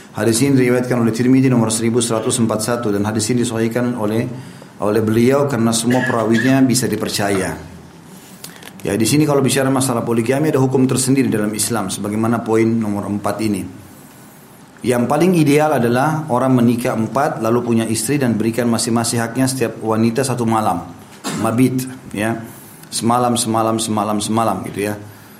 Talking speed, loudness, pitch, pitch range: 145 wpm, -17 LUFS, 115 Hz, 110-130 Hz